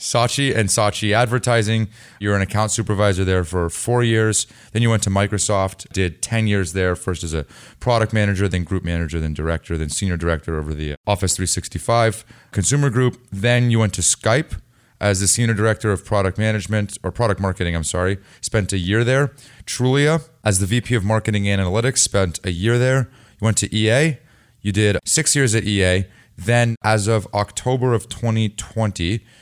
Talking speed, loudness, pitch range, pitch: 180 wpm, -19 LUFS, 95-115 Hz, 105 Hz